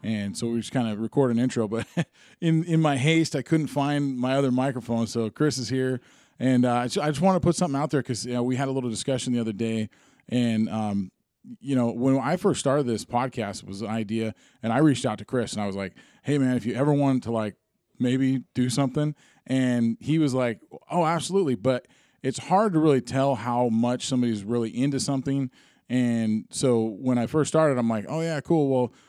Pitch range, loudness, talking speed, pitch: 115-145 Hz, -25 LUFS, 230 wpm, 130 Hz